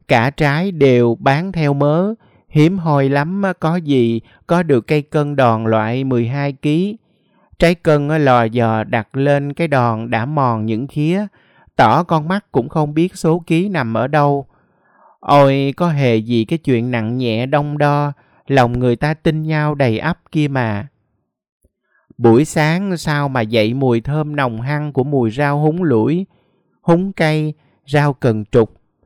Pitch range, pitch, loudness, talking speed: 120-160 Hz, 145 Hz, -16 LUFS, 165 wpm